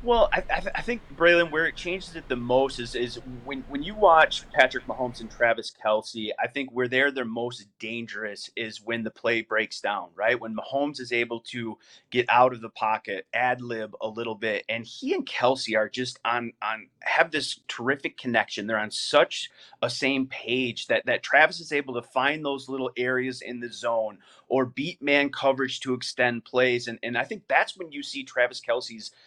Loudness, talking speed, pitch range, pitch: -26 LUFS, 205 wpm, 115-135 Hz, 125 Hz